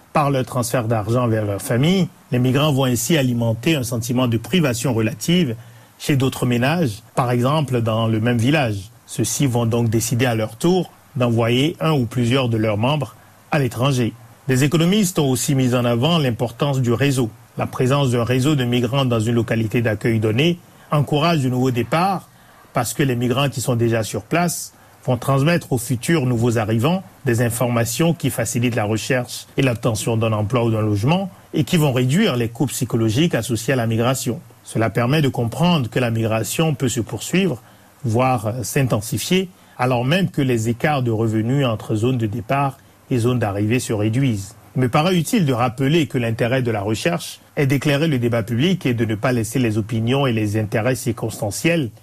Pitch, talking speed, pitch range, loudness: 125 Hz, 185 wpm, 115-140 Hz, -19 LUFS